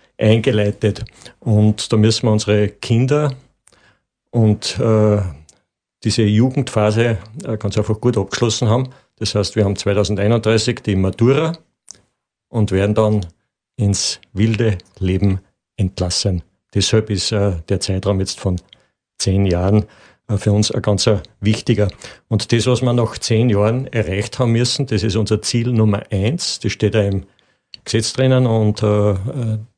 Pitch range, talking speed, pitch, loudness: 100-115 Hz, 140 wpm, 110 Hz, -17 LUFS